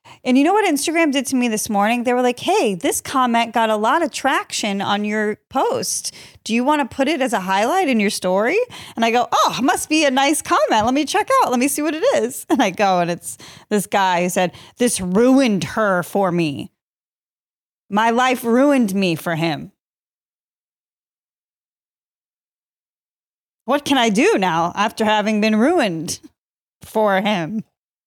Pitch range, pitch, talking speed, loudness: 200-280 Hz, 230 Hz, 185 wpm, -18 LUFS